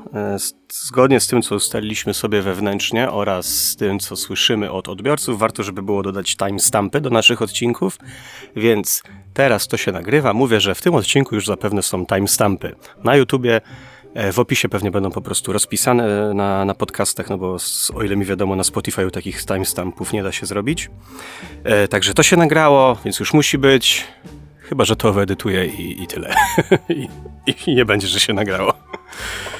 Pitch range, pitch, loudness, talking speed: 95-120 Hz, 105 Hz, -17 LUFS, 175 wpm